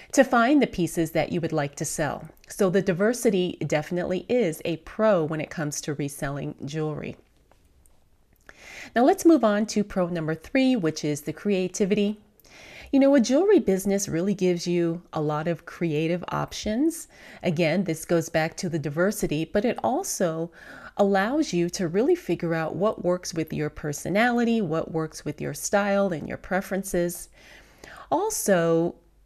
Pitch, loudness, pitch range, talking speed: 180 Hz, -25 LUFS, 160-210 Hz, 160 wpm